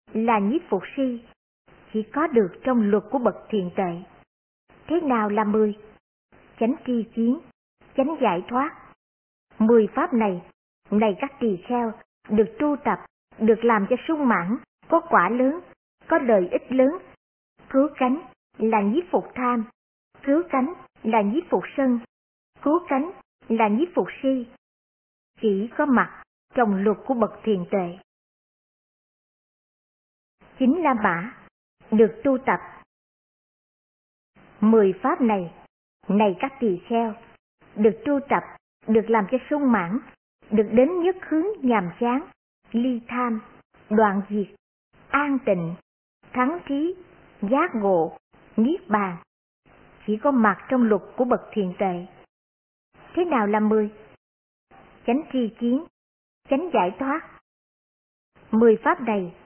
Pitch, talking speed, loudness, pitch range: 230 Hz, 135 wpm, -23 LUFS, 210-270 Hz